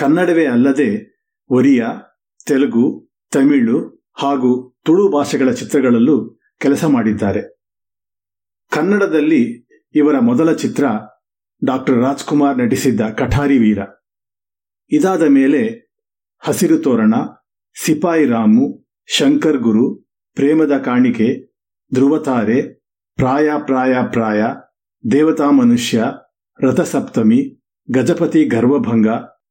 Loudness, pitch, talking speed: -15 LUFS, 150 Hz, 80 wpm